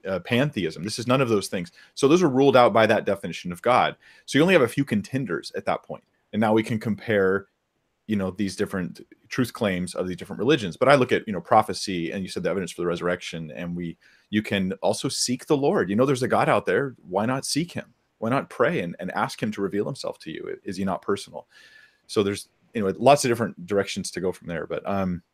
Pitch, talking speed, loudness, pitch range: 100 Hz, 255 wpm, -24 LUFS, 90-115 Hz